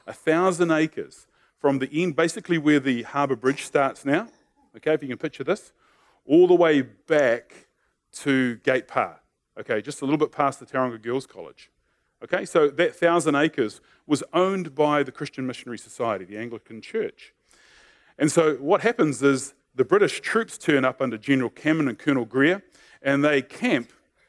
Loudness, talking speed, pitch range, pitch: -23 LUFS, 175 wpm, 130-175 Hz, 150 Hz